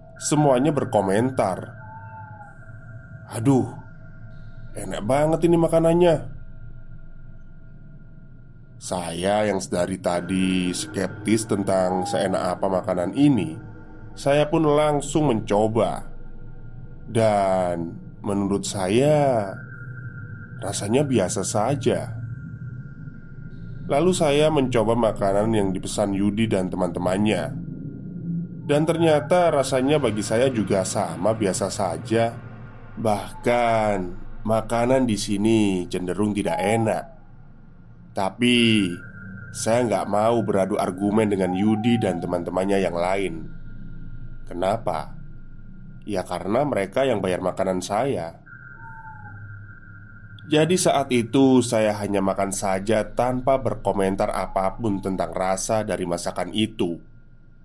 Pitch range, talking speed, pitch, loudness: 100-130 Hz, 90 wpm, 115 Hz, -22 LUFS